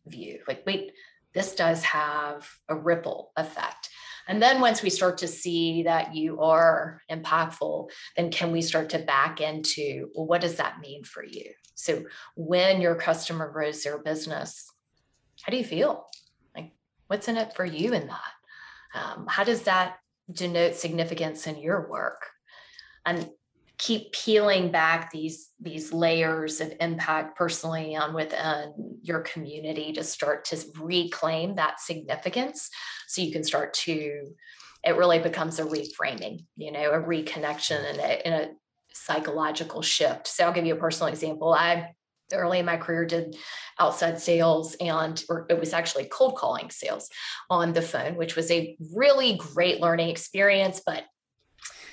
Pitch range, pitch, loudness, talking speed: 155-180 Hz, 165 Hz, -26 LUFS, 155 wpm